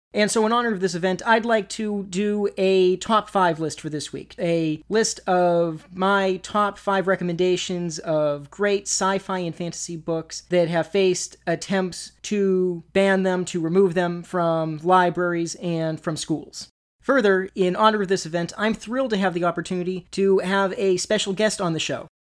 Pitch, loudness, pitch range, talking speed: 185 Hz, -22 LUFS, 170-195 Hz, 180 wpm